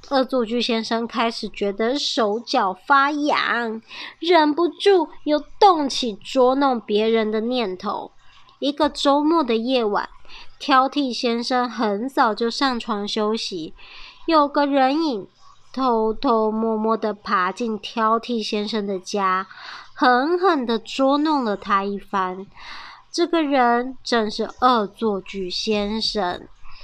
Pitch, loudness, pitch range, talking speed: 240 Hz, -21 LUFS, 215-280 Hz, 180 characters per minute